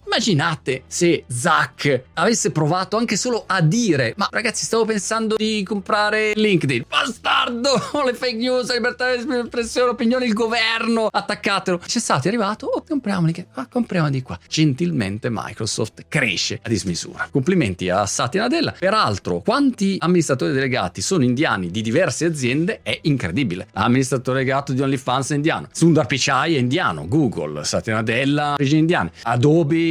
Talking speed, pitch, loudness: 140 wpm, 170 Hz, -20 LUFS